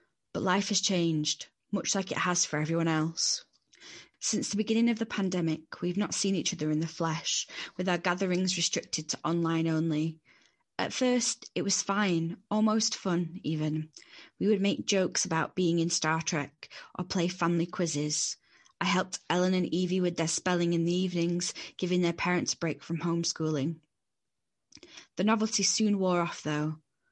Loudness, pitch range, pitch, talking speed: -30 LUFS, 160-190 Hz, 175 Hz, 170 wpm